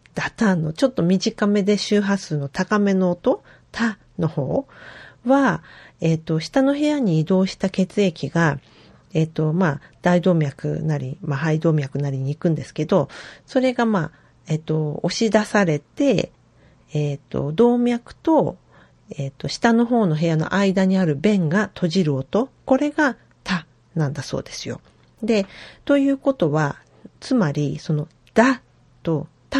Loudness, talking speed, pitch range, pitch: -21 LUFS, 255 characters per minute, 155-220 Hz, 180 Hz